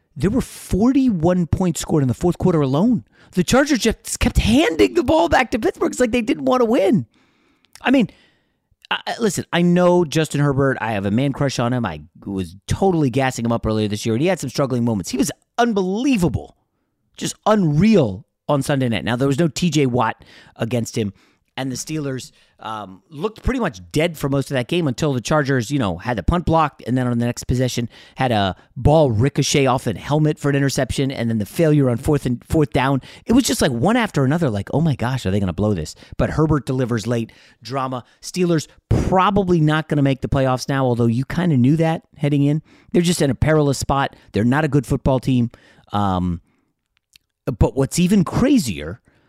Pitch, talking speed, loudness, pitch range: 140 Hz, 215 wpm, -19 LUFS, 120-175 Hz